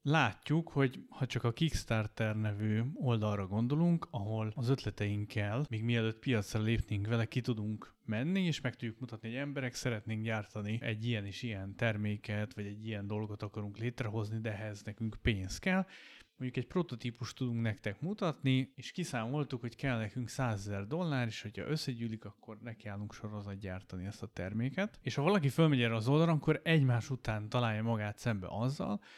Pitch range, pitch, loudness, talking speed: 105-130 Hz, 115 Hz, -36 LUFS, 165 wpm